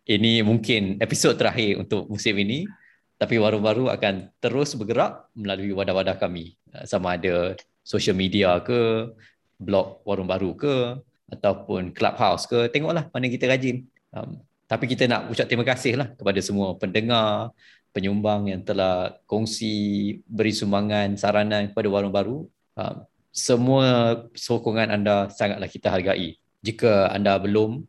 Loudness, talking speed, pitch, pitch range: -23 LUFS, 135 wpm, 110 Hz, 100-120 Hz